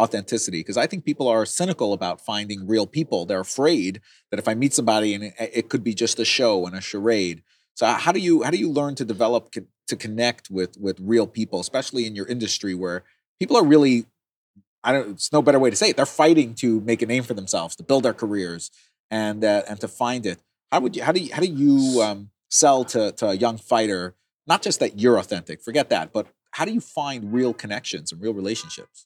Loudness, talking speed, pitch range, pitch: -22 LUFS, 235 wpm, 105-135 Hz, 115 Hz